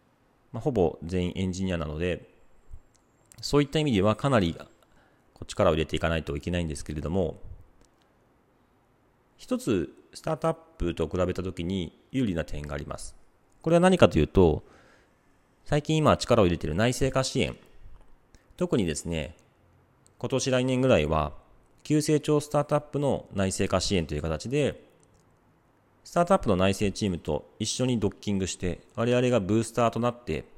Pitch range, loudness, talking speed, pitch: 85-130 Hz, -27 LUFS, 320 characters per minute, 105 Hz